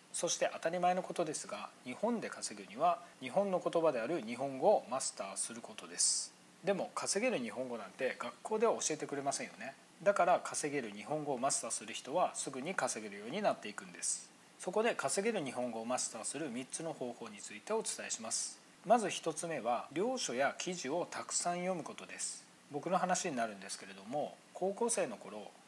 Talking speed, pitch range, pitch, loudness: 410 characters per minute, 130-185 Hz, 165 Hz, -37 LUFS